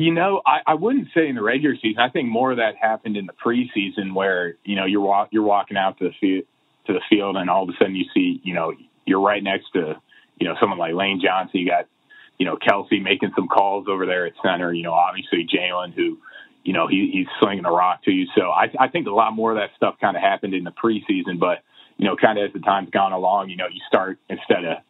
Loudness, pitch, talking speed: -21 LUFS, 105 Hz, 265 wpm